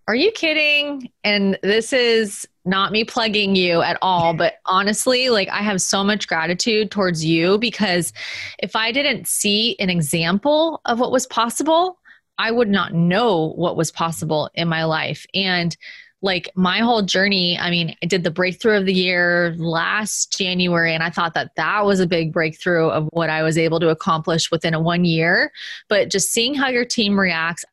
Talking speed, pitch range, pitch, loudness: 185 wpm, 170-220 Hz, 190 Hz, -18 LUFS